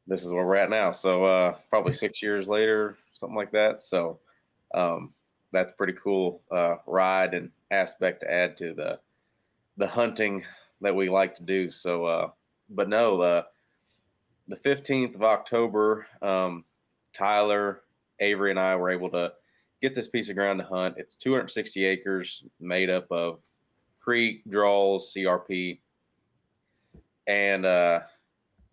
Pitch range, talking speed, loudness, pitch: 90-105 Hz, 145 wpm, -26 LUFS, 95 Hz